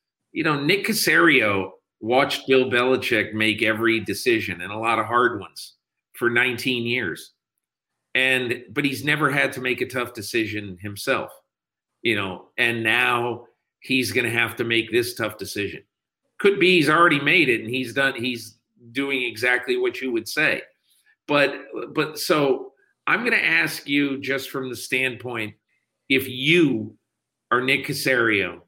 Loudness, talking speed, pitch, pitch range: -21 LUFS, 160 wpm, 130 Hz, 115-140 Hz